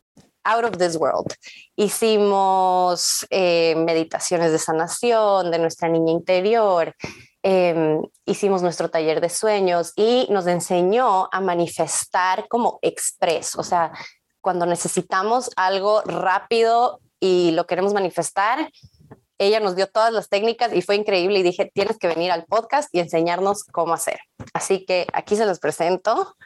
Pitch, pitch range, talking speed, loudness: 185 Hz, 170-205 Hz, 140 wpm, -20 LUFS